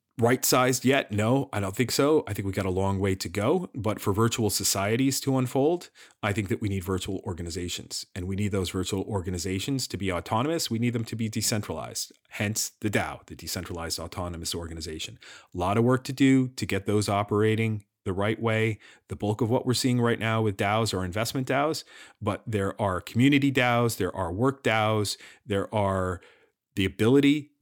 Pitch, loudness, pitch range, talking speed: 105 Hz, -27 LUFS, 95-125 Hz, 200 wpm